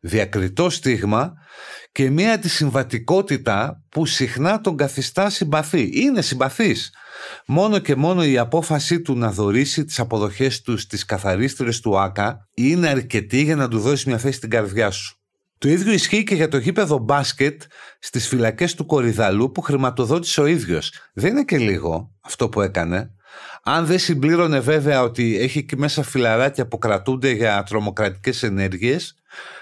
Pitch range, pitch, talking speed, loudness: 115-160 Hz, 135 Hz, 150 wpm, -20 LUFS